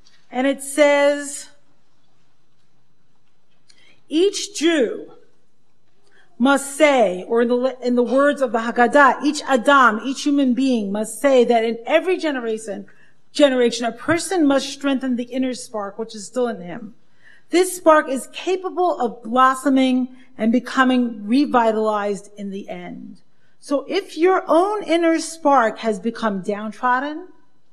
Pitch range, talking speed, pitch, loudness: 230-295 Hz, 130 wpm, 260 Hz, -19 LUFS